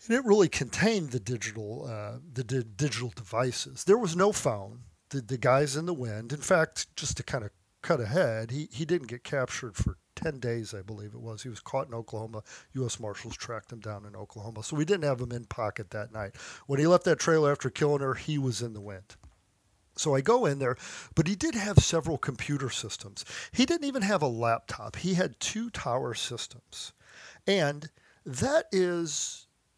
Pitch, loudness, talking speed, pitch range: 130 Hz, -29 LUFS, 205 wpm, 110-160 Hz